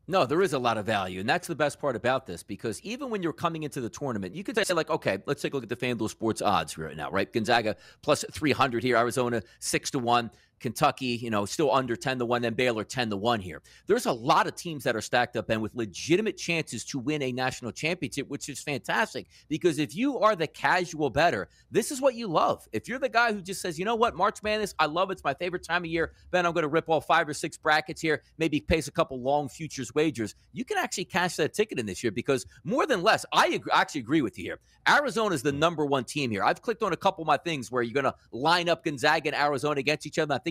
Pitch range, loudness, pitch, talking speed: 125-170 Hz, -27 LUFS, 150 Hz, 270 wpm